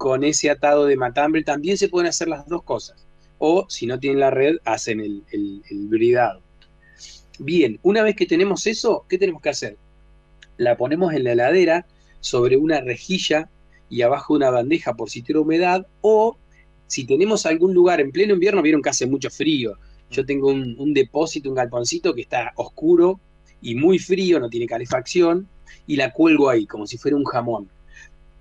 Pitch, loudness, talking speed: 170 Hz, -20 LUFS, 185 wpm